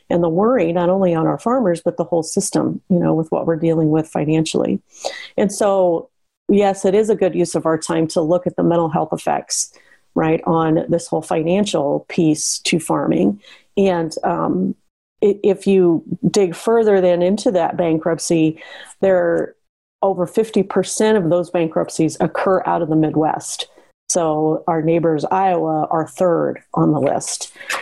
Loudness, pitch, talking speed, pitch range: -18 LUFS, 175 Hz, 165 wpm, 165-195 Hz